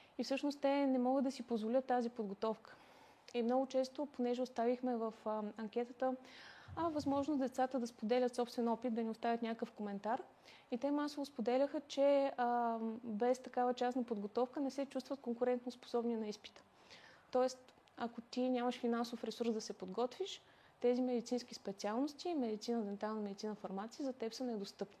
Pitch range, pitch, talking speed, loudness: 230-260 Hz, 245 Hz, 160 wpm, -40 LUFS